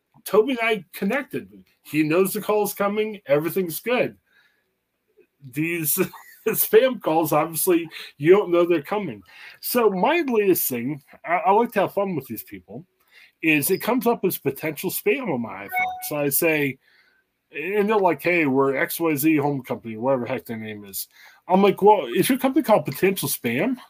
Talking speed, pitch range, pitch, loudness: 175 wpm, 155-215 Hz, 185 Hz, -22 LUFS